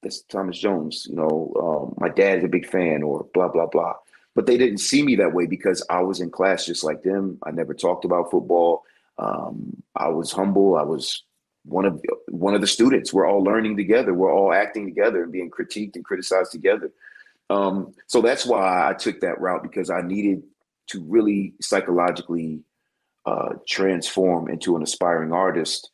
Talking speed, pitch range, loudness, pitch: 190 wpm, 85-105 Hz, -22 LUFS, 95 Hz